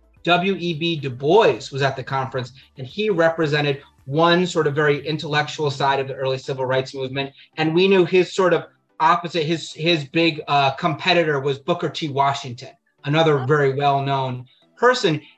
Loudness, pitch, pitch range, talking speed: -20 LUFS, 150 Hz, 135-170 Hz, 170 wpm